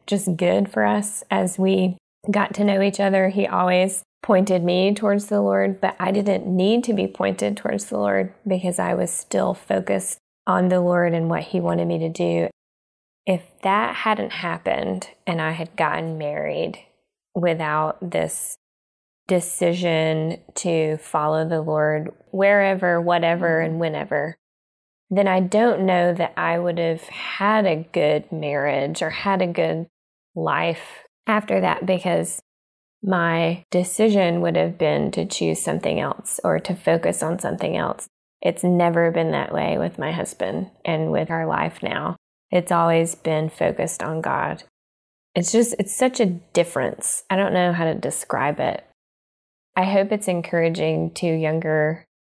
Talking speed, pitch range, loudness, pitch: 155 wpm, 150-190 Hz, -22 LUFS, 170 Hz